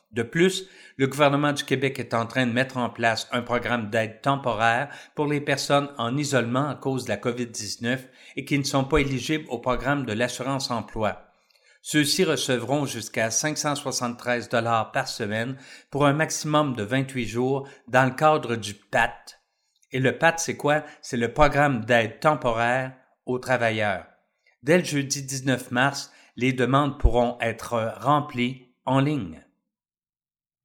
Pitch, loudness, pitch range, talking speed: 130 Hz, -24 LUFS, 120-140 Hz, 155 wpm